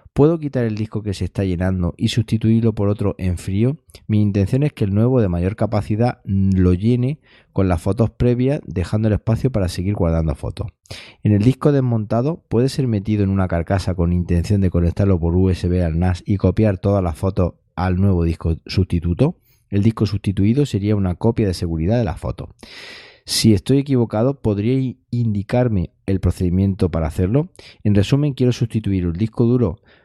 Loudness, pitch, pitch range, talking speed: -19 LUFS, 105 Hz, 90-120 Hz, 180 wpm